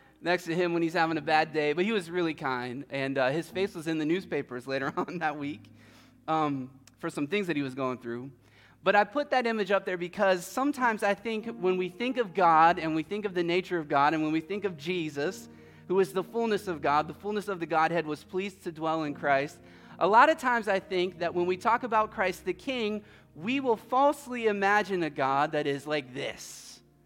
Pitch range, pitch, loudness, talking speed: 145-205 Hz, 170 Hz, -29 LUFS, 235 wpm